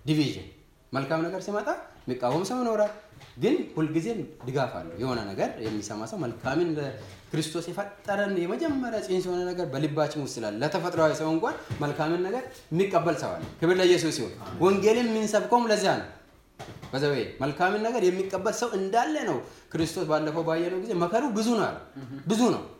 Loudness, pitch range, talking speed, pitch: -28 LUFS, 150-200 Hz, 145 wpm, 170 Hz